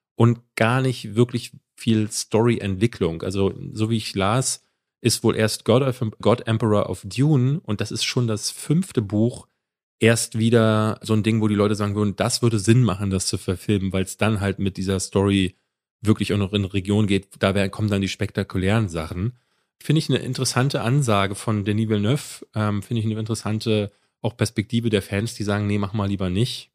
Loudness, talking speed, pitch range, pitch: -22 LUFS, 195 wpm, 100-115 Hz, 110 Hz